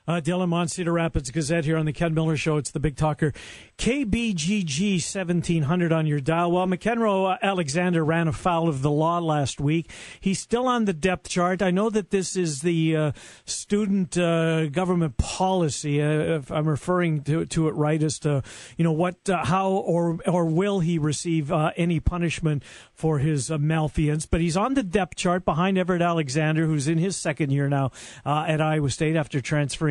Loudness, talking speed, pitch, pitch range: -24 LUFS, 195 wpm, 165 Hz, 155-180 Hz